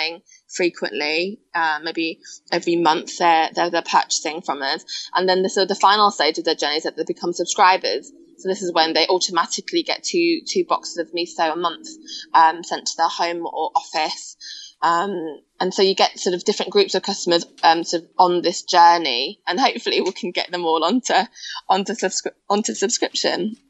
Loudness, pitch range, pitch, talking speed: -20 LUFS, 170-205 Hz, 180 Hz, 190 wpm